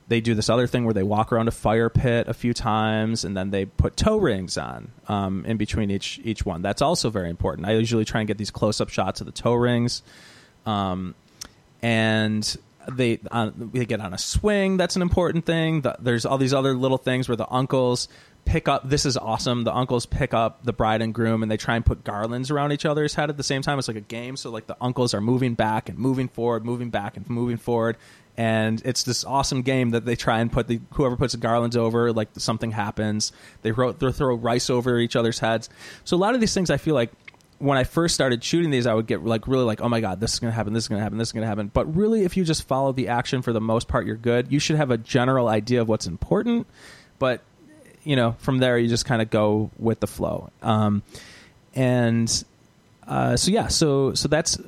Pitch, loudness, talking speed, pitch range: 120 Hz, -23 LUFS, 240 wpm, 110-130 Hz